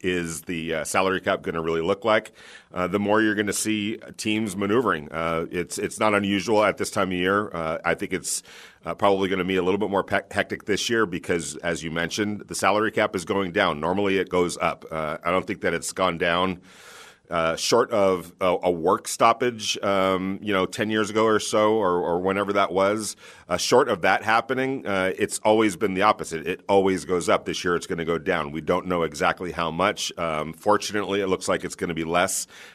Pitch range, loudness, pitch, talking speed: 85-105 Hz, -24 LUFS, 95 Hz, 230 wpm